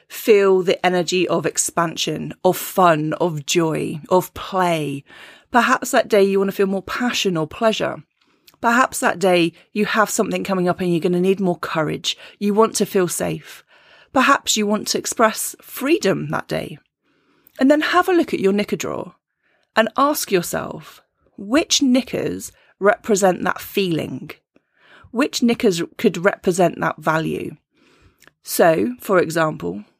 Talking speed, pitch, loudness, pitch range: 150 wpm, 200 Hz, -19 LUFS, 180-240 Hz